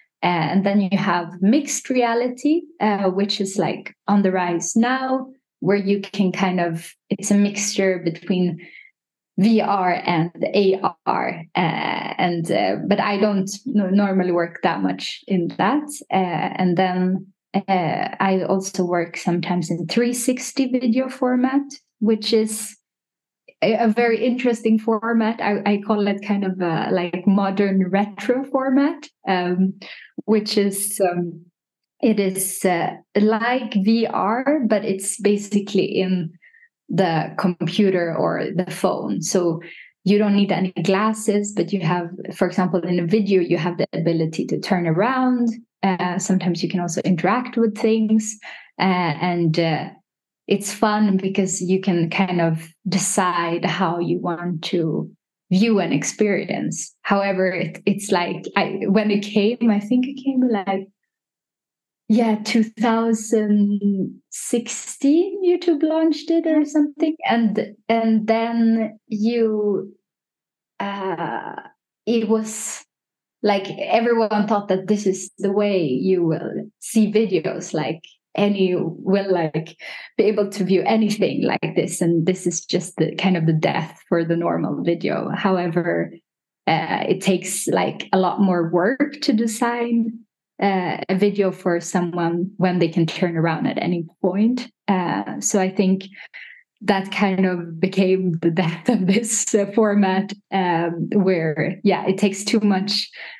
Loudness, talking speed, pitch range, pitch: -20 LUFS, 140 wpm, 180-220 Hz, 195 Hz